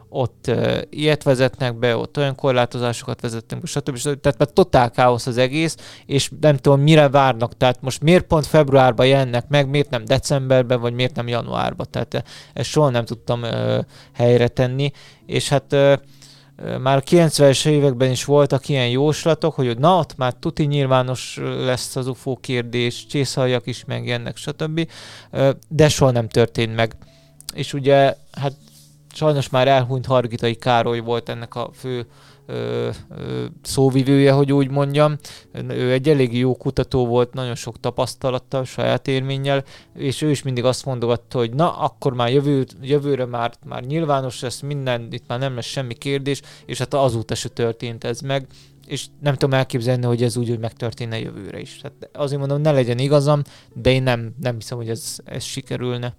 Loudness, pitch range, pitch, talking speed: -19 LUFS, 120-140 Hz, 130 Hz, 170 wpm